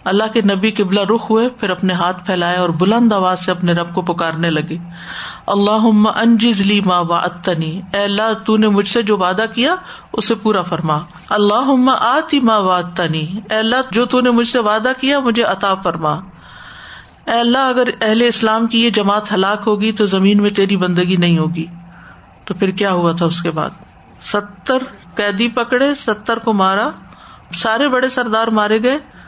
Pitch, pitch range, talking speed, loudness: 210 Hz, 185-230 Hz, 180 wpm, -15 LUFS